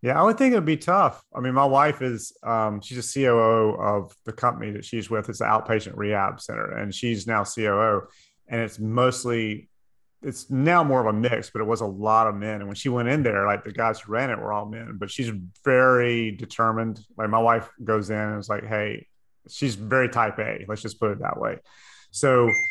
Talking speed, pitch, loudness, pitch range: 230 wpm, 115 Hz, -24 LUFS, 105-125 Hz